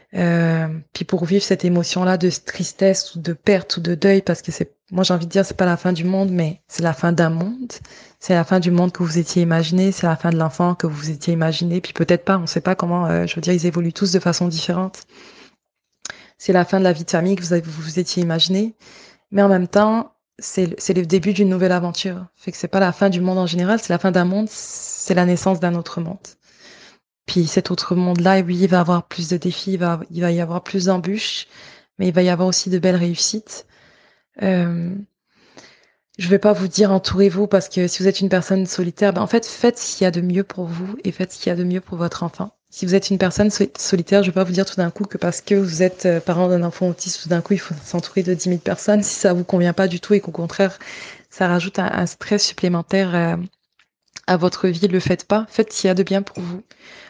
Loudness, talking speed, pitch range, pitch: -19 LUFS, 265 wpm, 175-195 Hz, 185 Hz